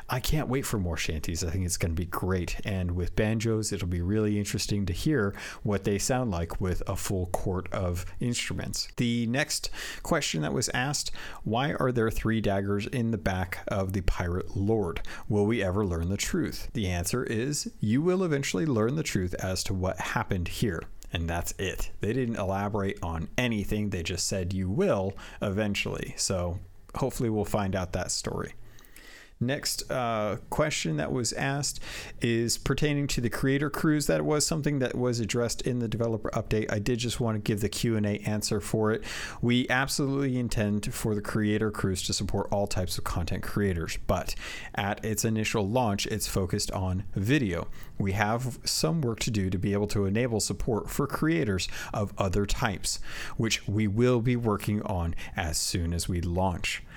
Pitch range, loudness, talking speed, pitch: 95-120 Hz, -29 LUFS, 185 wpm, 105 Hz